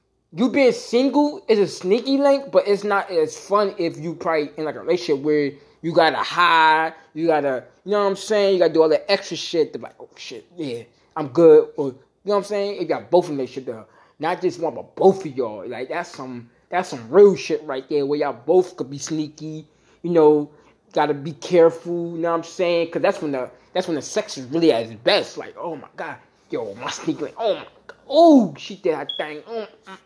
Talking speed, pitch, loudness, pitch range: 240 wpm, 170 Hz, -20 LUFS, 150-205 Hz